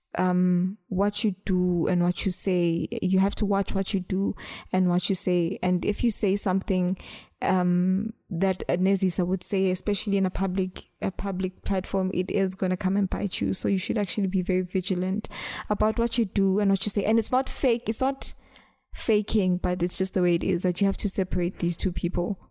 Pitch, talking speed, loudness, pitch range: 190 Hz, 215 wpm, -25 LUFS, 180-200 Hz